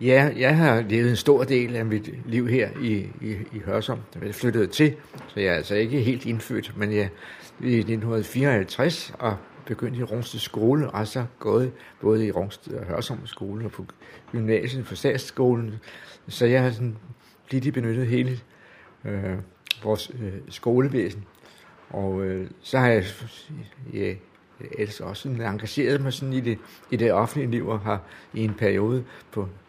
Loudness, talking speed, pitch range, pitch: -25 LUFS, 175 wpm, 105-130 Hz, 115 Hz